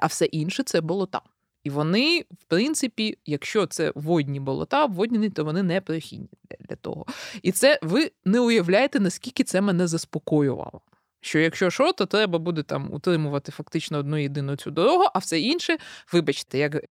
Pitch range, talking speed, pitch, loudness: 150-215 Hz, 165 wpm, 175 Hz, -24 LUFS